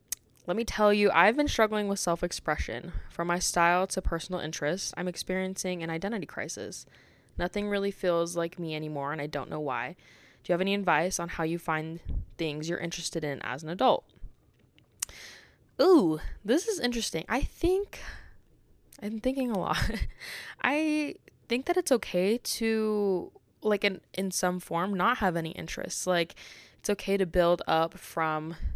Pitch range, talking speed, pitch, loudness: 170-210 Hz, 165 wpm, 185 Hz, -29 LUFS